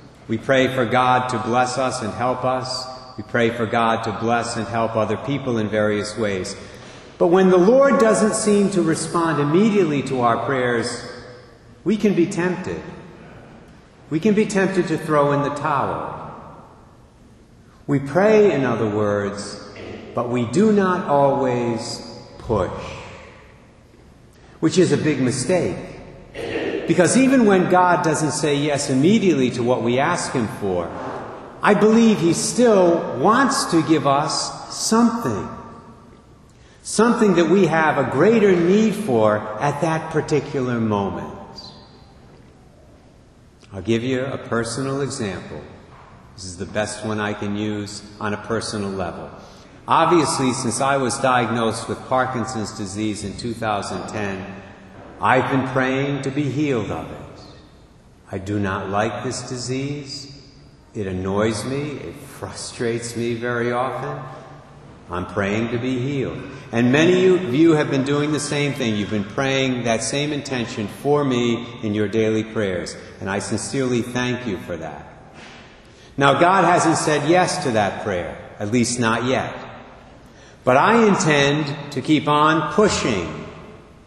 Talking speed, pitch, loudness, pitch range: 145 wpm, 130 Hz, -20 LUFS, 110-155 Hz